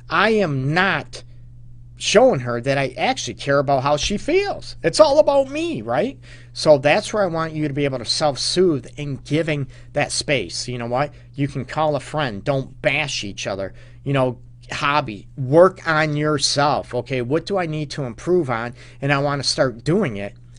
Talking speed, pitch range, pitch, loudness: 190 wpm, 120-155 Hz, 140 Hz, -20 LUFS